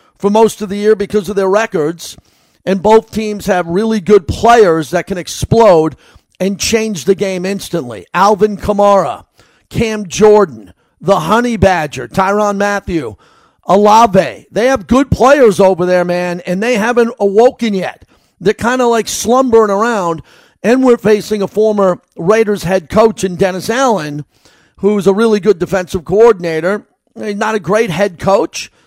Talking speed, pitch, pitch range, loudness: 155 wpm, 205 Hz, 185-220 Hz, -12 LUFS